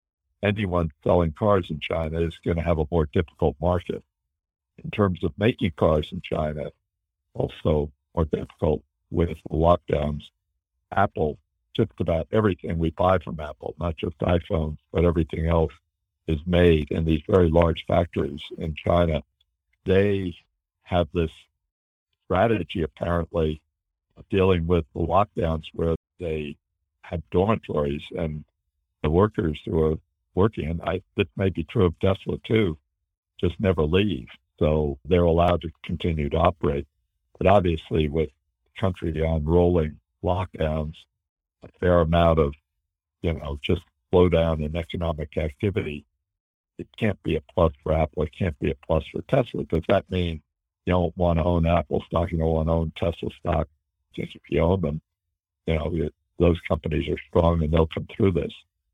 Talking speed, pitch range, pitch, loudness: 155 wpm, 80-90 Hz, 85 Hz, -25 LUFS